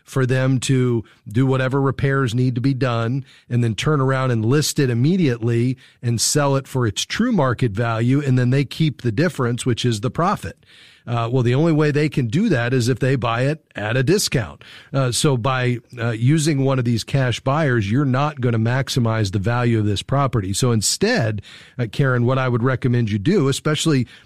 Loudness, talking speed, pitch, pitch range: -19 LUFS, 210 wpm, 130 Hz, 120-140 Hz